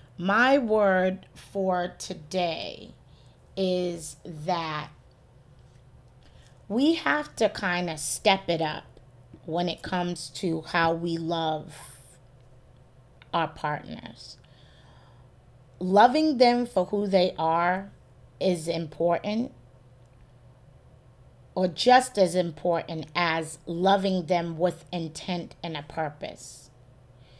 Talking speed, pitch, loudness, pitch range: 95 wpm, 170 Hz, -26 LUFS, 135-185 Hz